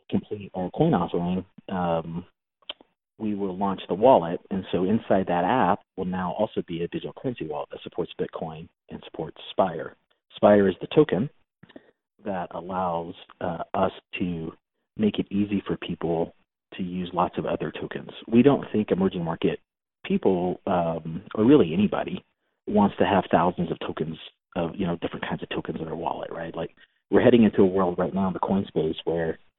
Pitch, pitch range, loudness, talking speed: 95 Hz, 85-100 Hz, -25 LUFS, 180 wpm